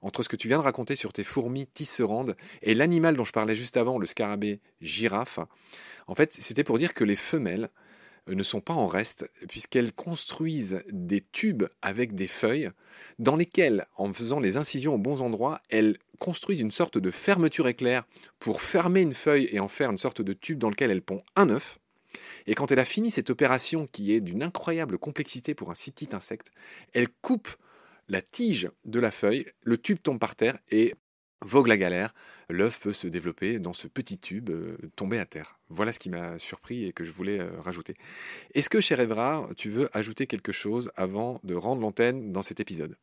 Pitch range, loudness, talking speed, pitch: 105-150 Hz, -28 LUFS, 200 wpm, 120 Hz